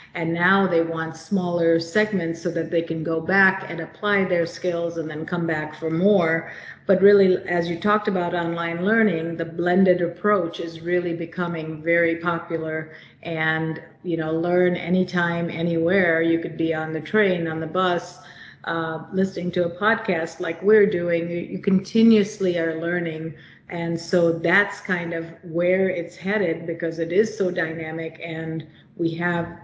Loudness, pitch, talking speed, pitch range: -22 LUFS, 170 Hz, 165 wpm, 165-185 Hz